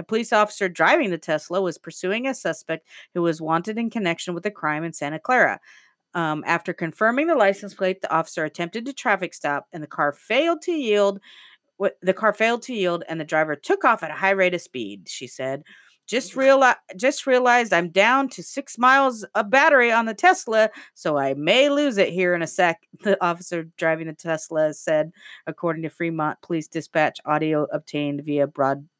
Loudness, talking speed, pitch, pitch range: -22 LUFS, 195 wpm, 175 Hz, 160-220 Hz